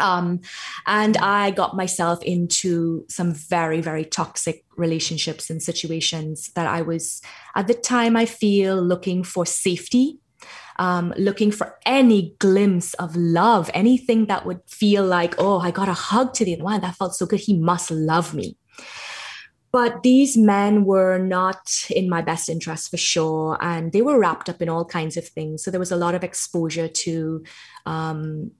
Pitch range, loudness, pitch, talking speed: 165-200 Hz, -21 LUFS, 180 Hz, 170 wpm